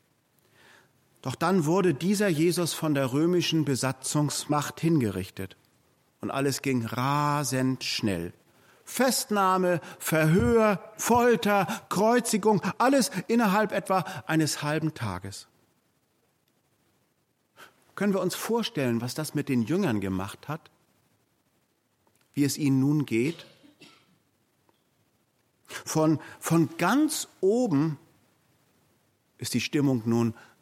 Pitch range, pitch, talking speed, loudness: 130-195 Hz, 155 Hz, 95 wpm, -26 LUFS